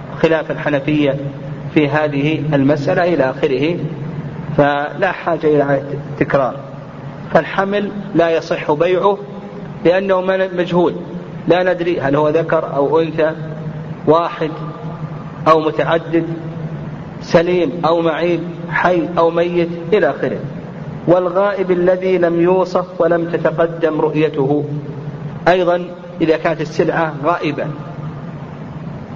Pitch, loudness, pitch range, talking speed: 160 Hz, -16 LUFS, 150-175 Hz, 95 wpm